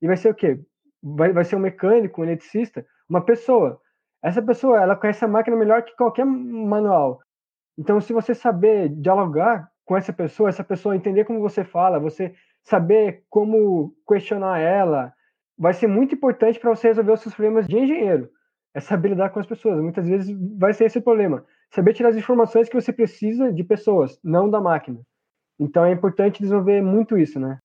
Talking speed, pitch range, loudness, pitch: 185 wpm, 185-225 Hz, -20 LUFS, 210 Hz